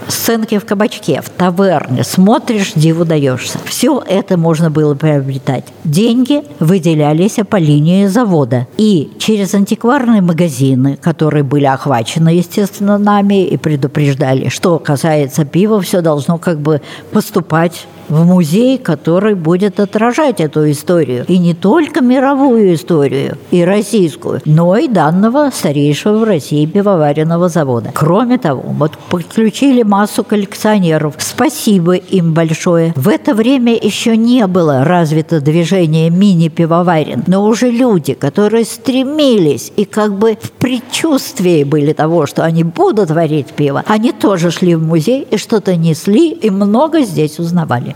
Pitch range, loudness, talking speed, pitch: 155-215 Hz, -11 LUFS, 135 wpm, 180 Hz